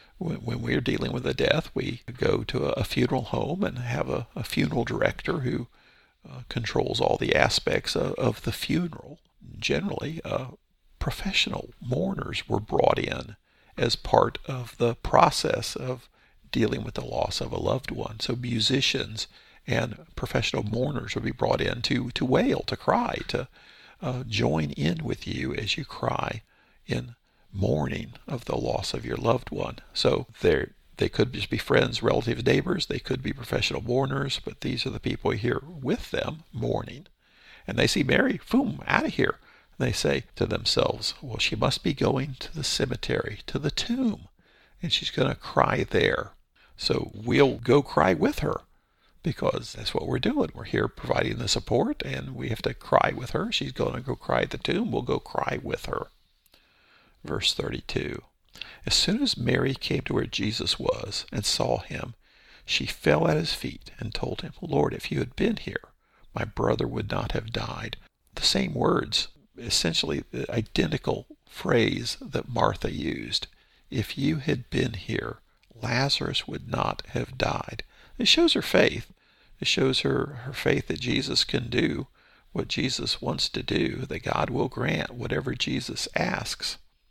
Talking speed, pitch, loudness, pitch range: 170 wpm, 130 Hz, -27 LUFS, 120-150 Hz